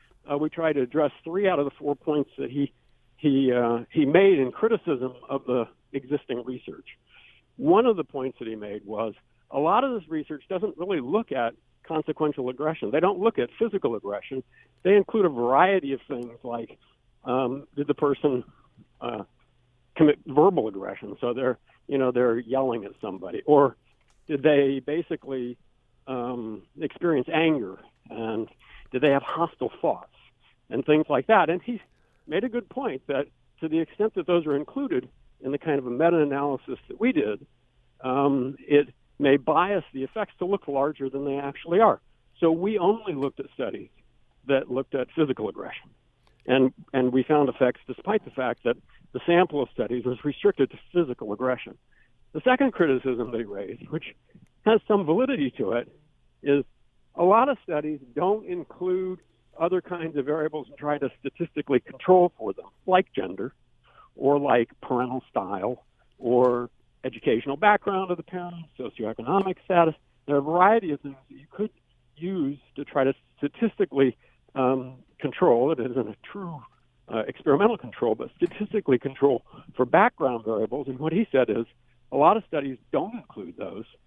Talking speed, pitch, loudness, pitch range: 170 wpm, 140 Hz, -25 LUFS, 125-175 Hz